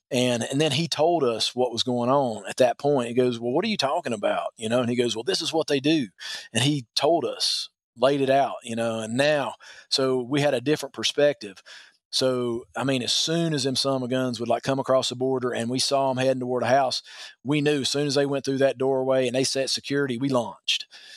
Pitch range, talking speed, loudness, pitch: 125-140 Hz, 250 wpm, -24 LUFS, 130 Hz